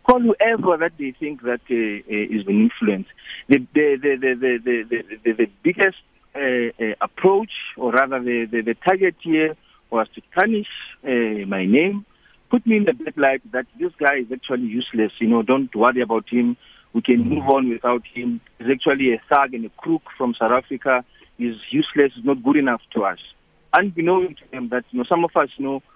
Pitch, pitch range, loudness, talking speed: 135 Hz, 120-180 Hz, -20 LUFS, 205 wpm